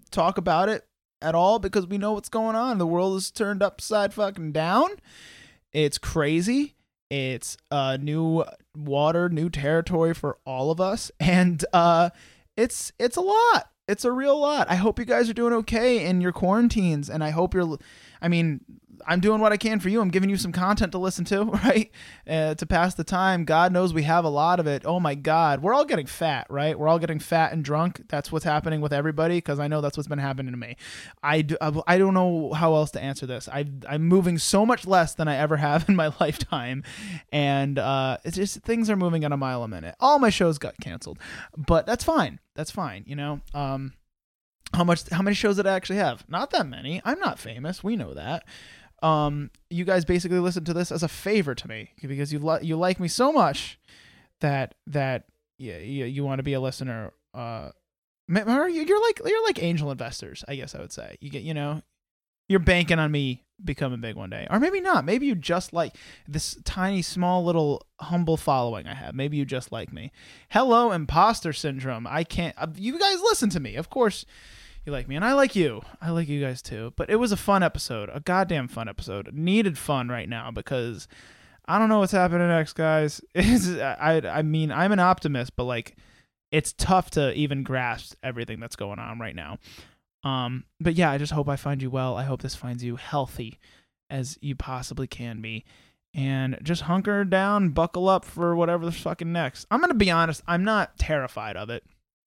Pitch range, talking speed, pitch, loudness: 140-190 Hz, 210 wpm, 160 Hz, -25 LUFS